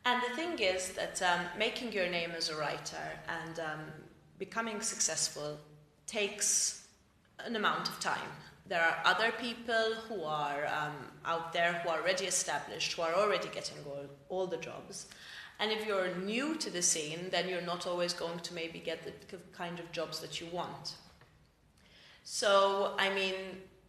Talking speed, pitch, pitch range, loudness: 170 wpm, 175 Hz, 165-200 Hz, -34 LUFS